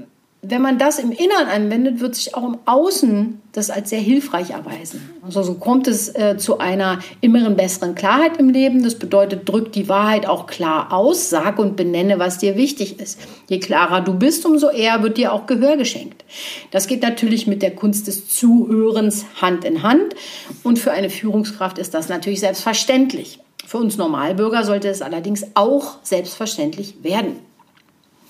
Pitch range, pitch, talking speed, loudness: 195-260 Hz, 215 Hz, 175 wpm, -17 LUFS